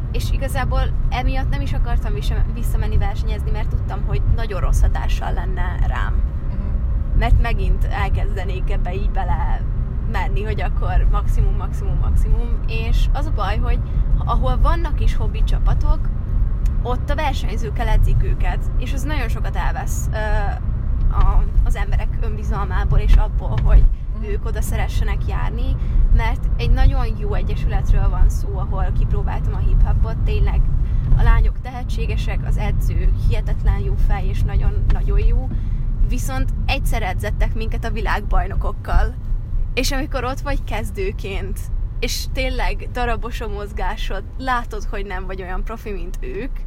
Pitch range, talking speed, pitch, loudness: 75-115 Hz, 140 wpm, 105 Hz, -22 LUFS